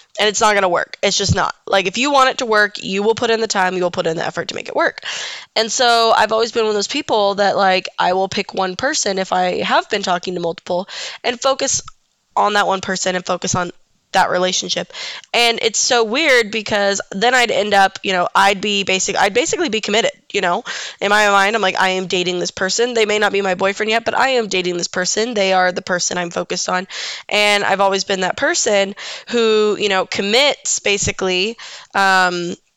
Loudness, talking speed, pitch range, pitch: -16 LUFS, 235 wpm, 185-225 Hz, 200 Hz